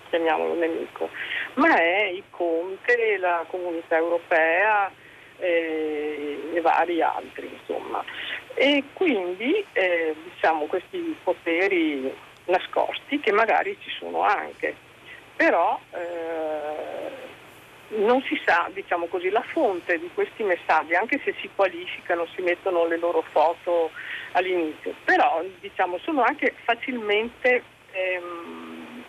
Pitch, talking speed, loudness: 185 Hz, 110 wpm, -24 LUFS